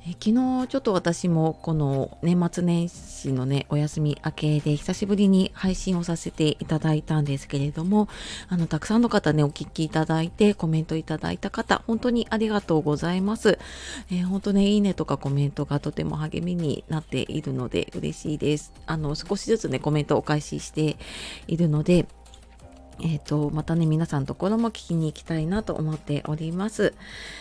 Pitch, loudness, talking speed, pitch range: 160 Hz, -25 LUFS, 370 characters per minute, 150-190 Hz